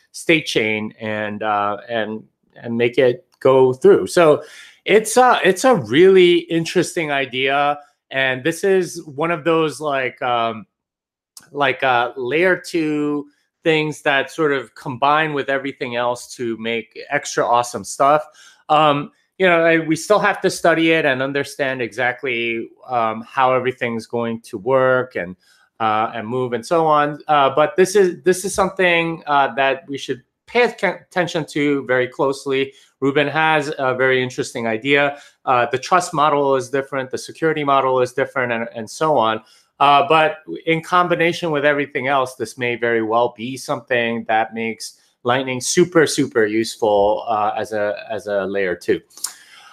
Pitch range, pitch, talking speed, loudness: 120-165 Hz, 140 Hz, 160 wpm, -18 LUFS